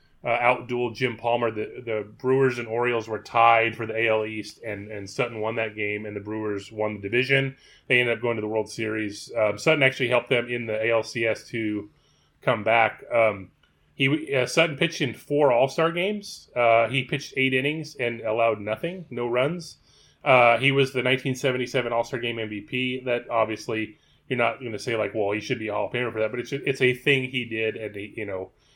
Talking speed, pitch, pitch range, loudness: 215 wpm, 120 Hz, 110-130 Hz, -24 LUFS